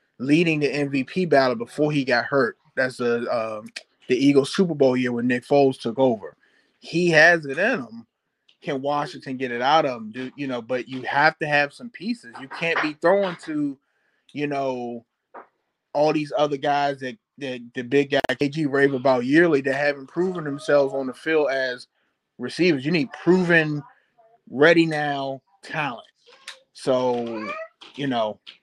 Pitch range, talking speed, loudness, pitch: 130-160 Hz, 170 wpm, -22 LUFS, 140 Hz